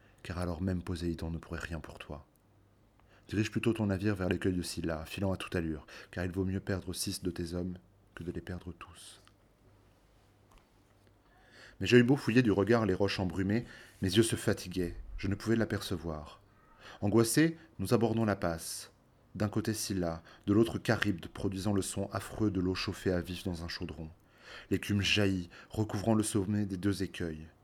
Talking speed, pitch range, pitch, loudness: 180 wpm, 90-105 Hz, 100 Hz, -33 LUFS